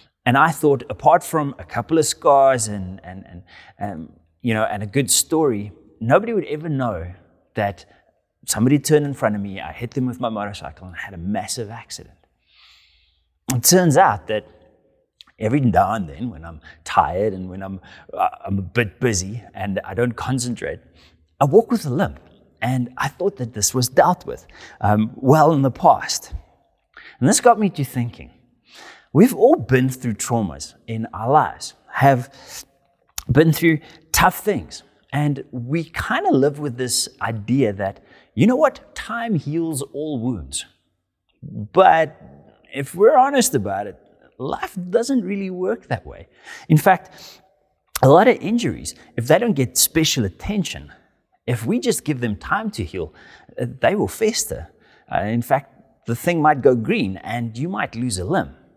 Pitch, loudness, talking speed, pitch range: 125 Hz, -19 LUFS, 170 wpm, 105-155 Hz